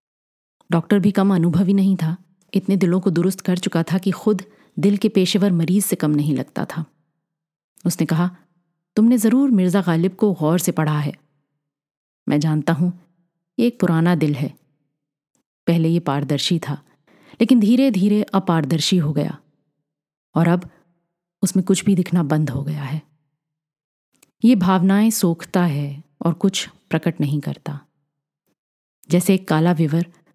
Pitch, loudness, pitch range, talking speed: 170 Hz, -19 LUFS, 150-190 Hz, 150 wpm